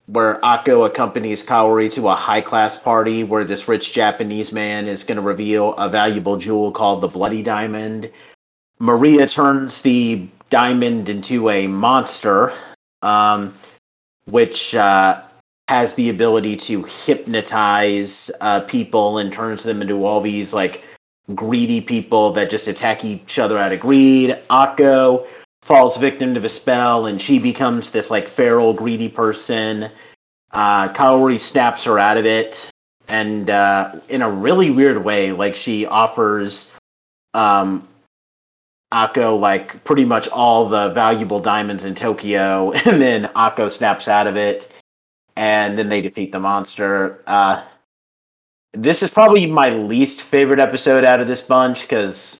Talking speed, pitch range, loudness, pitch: 145 wpm, 100-125 Hz, -16 LUFS, 110 Hz